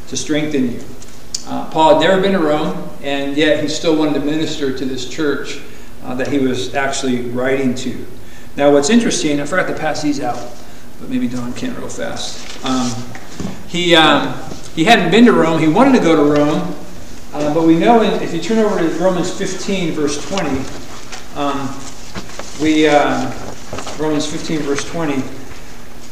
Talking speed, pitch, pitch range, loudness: 175 wpm, 150 Hz, 130-165 Hz, -16 LUFS